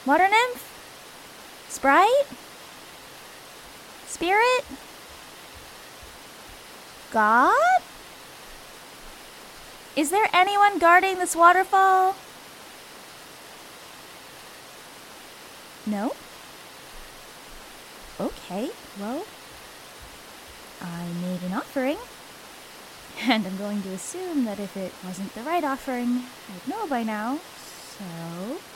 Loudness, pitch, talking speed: -23 LUFS, 275 Hz, 75 wpm